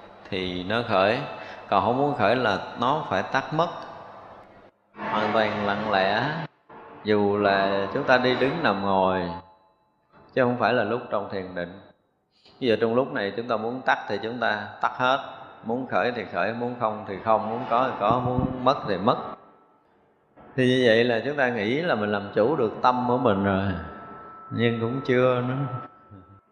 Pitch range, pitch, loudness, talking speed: 100-125 Hz, 110 Hz, -24 LUFS, 185 wpm